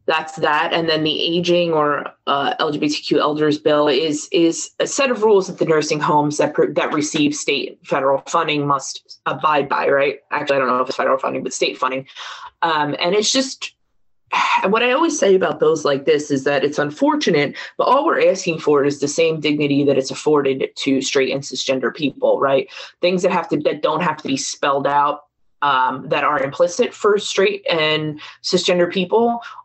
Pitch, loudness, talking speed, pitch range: 160 Hz, -18 LUFS, 200 wpm, 145-235 Hz